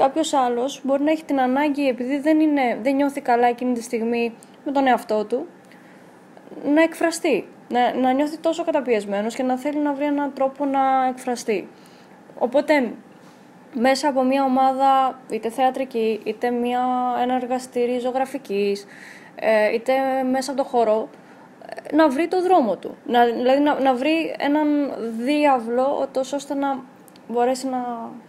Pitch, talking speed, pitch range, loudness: 265 Hz, 150 wpm, 245-285 Hz, -21 LUFS